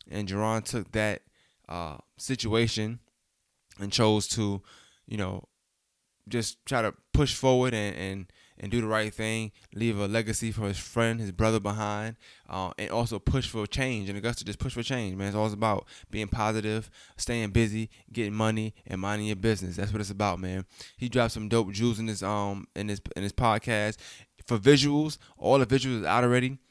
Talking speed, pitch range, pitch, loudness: 185 wpm, 100-115 Hz, 110 Hz, -29 LUFS